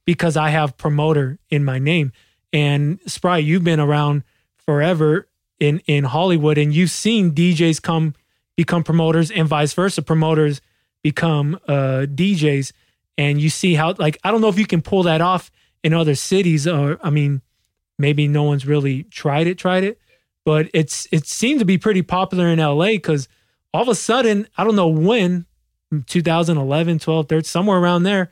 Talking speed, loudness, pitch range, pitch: 175 wpm, -18 LUFS, 145-180 Hz, 160 Hz